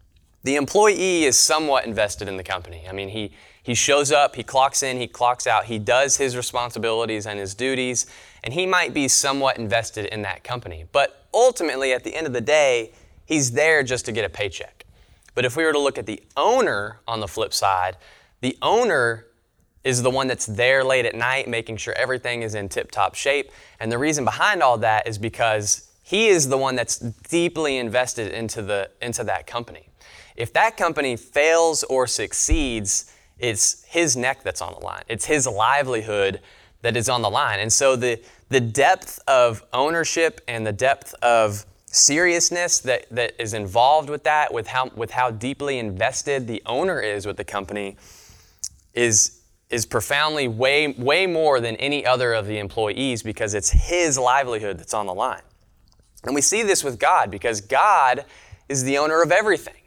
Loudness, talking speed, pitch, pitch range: -21 LUFS, 185 wpm, 120 Hz, 110-140 Hz